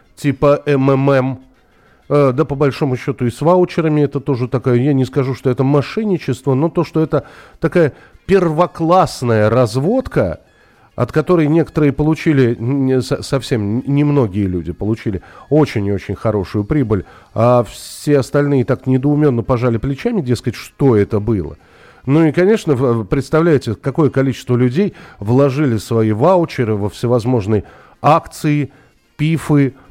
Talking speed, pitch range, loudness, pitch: 130 wpm, 120-150 Hz, -15 LUFS, 135 Hz